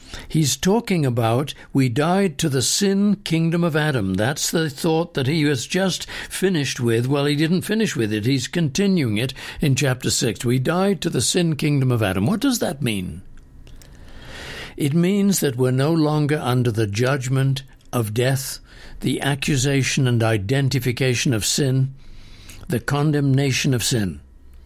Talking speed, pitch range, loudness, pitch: 160 wpm, 120-160 Hz, -20 LUFS, 135 Hz